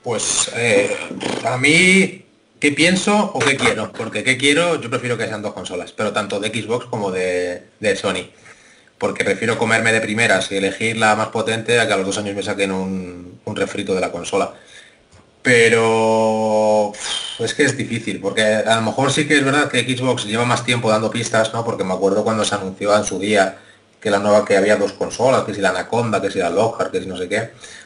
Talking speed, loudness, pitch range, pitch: 220 wpm, -18 LUFS, 105-125 Hz, 110 Hz